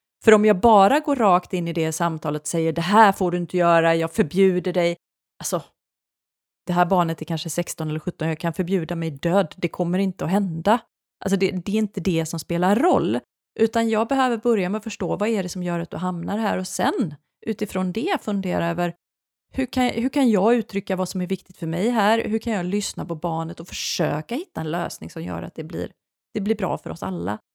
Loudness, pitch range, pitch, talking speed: -22 LUFS, 170-215 Hz, 185 Hz, 230 wpm